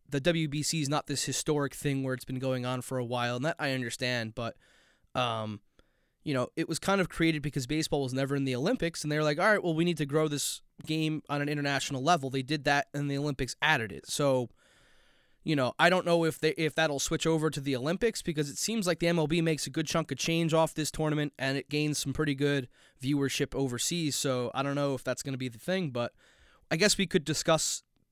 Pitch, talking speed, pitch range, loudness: 150 Hz, 245 wpm, 135-160 Hz, -30 LUFS